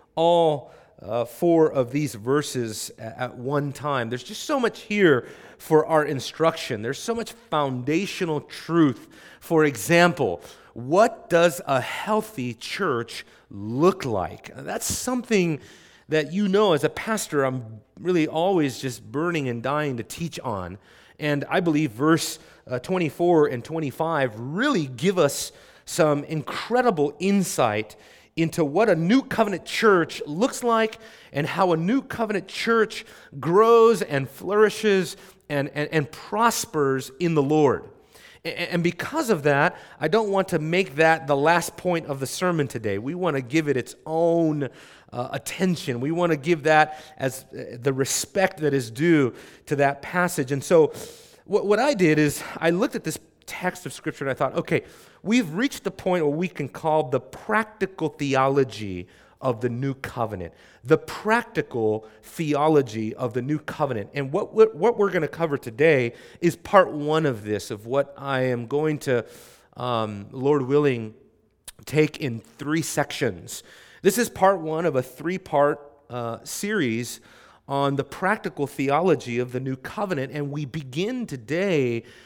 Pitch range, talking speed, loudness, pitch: 130-180 Hz, 160 wpm, -24 LUFS, 155 Hz